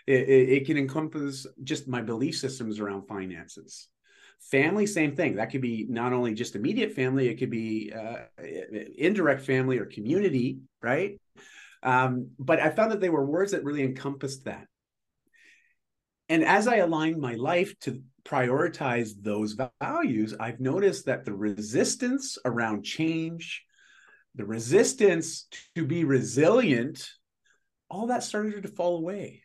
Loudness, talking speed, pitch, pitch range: -27 LUFS, 145 wpm, 135 Hz, 120-175 Hz